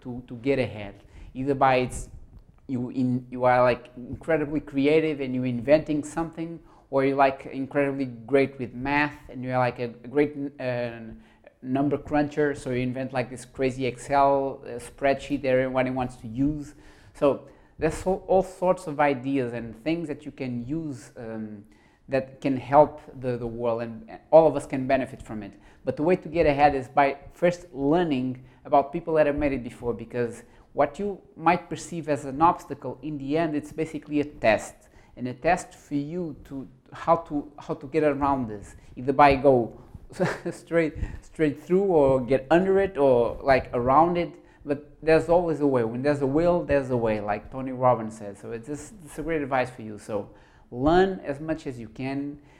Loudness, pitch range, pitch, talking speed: -25 LUFS, 125-150 Hz, 140 Hz, 185 wpm